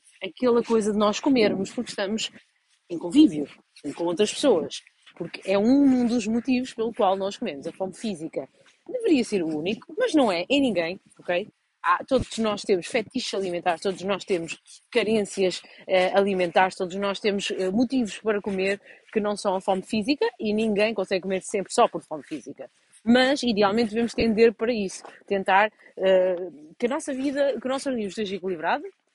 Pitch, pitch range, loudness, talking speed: 210 Hz, 190-245 Hz, -24 LUFS, 175 wpm